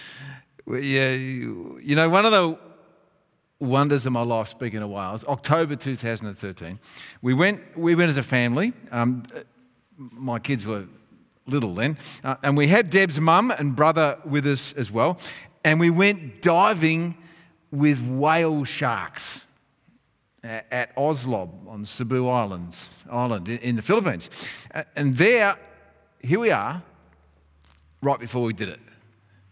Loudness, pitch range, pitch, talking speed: -23 LUFS, 115-155 Hz, 130 Hz, 140 wpm